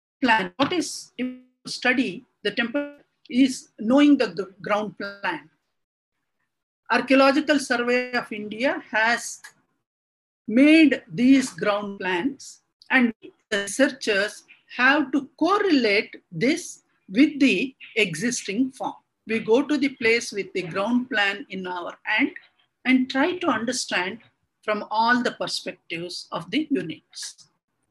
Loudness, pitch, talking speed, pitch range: -23 LUFS, 250 Hz, 115 wpm, 215-280 Hz